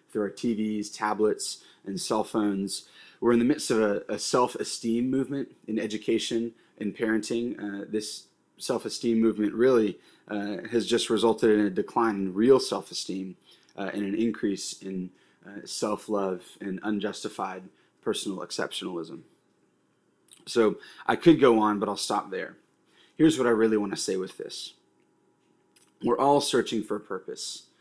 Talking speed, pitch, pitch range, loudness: 160 wpm, 110 Hz, 100-115 Hz, -27 LUFS